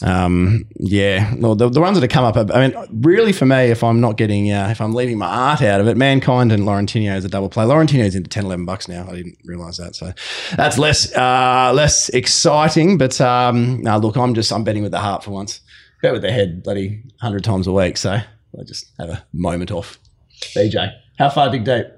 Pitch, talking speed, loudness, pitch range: 110 Hz, 230 wpm, -16 LUFS, 100-125 Hz